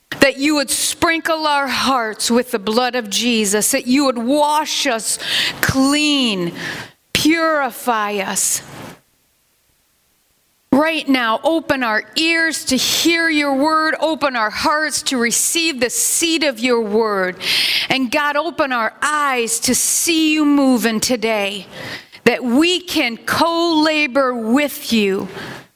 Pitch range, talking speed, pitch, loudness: 235-305 Hz, 130 wpm, 275 Hz, -16 LUFS